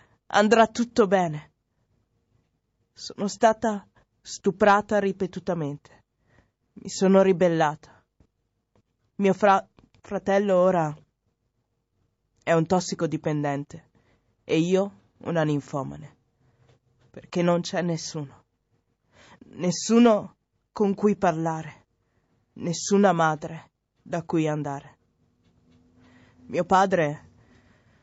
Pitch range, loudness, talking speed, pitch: 125-195 Hz, -24 LUFS, 75 wpm, 165 Hz